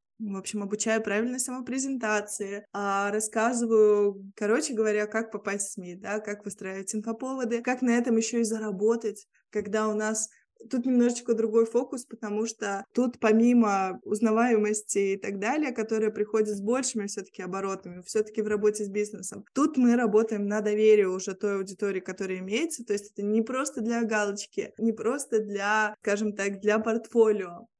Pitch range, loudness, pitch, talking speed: 205-230 Hz, -27 LUFS, 215 Hz, 155 wpm